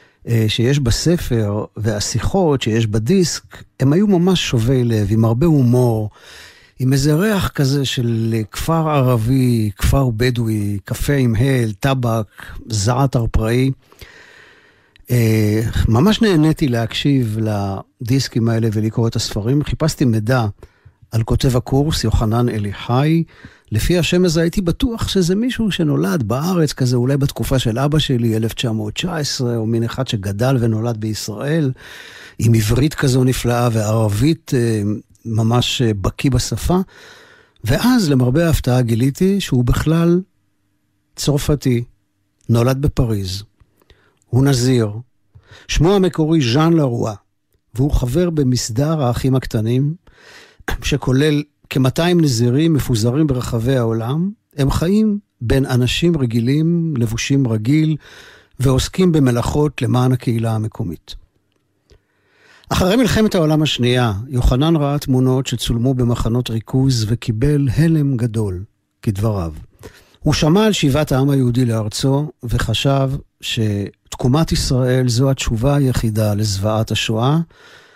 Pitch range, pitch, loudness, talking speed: 110-145 Hz, 125 Hz, -17 LUFS, 110 wpm